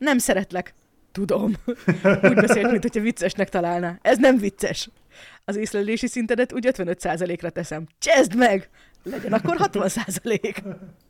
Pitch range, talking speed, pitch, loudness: 185-240 Hz, 120 wpm, 200 Hz, -22 LUFS